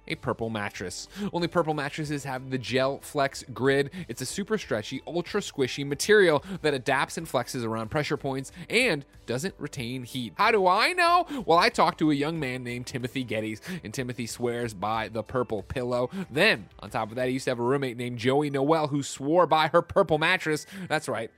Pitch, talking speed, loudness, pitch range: 140 Hz, 200 wpm, -27 LUFS, 125-165 Hz